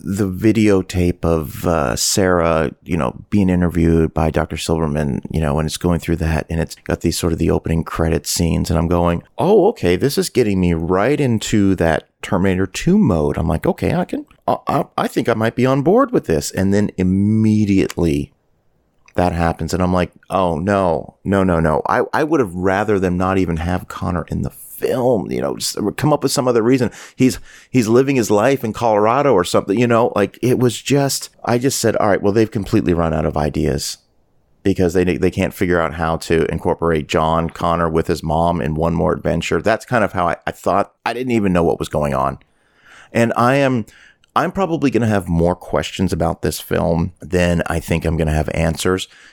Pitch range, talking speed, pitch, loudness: 80-105 Hz, 215 wpm, 90 Hz, -17 LUFS